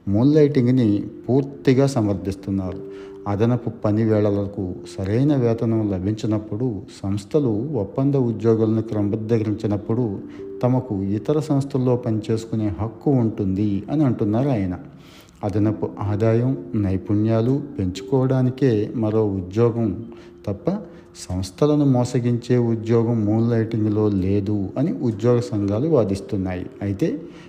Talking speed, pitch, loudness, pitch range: 85 wpm, 110 Hz, -21 LUFS, 100-125 Hz